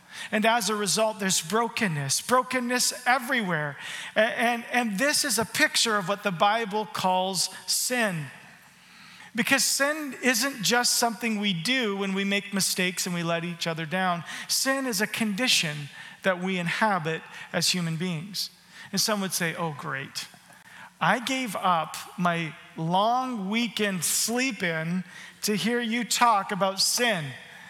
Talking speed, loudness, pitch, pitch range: 145 wpm, -25 LUFS, 205 Hz, 180-235 Hz